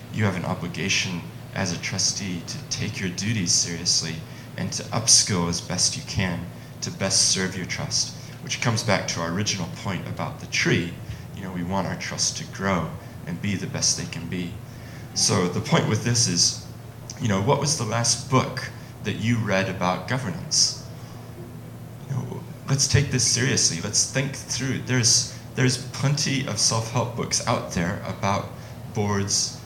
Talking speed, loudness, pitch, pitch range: 175 wpm, -23 LUFS, 120 Hz, 100-130 Hz